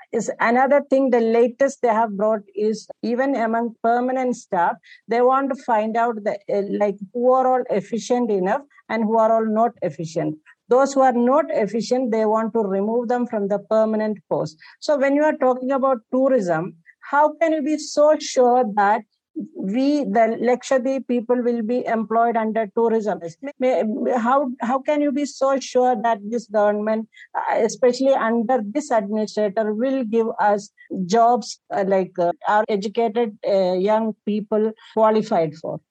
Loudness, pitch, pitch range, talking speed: -20 LUFS, 230 Hz, 215-260 Hz, 155 wpm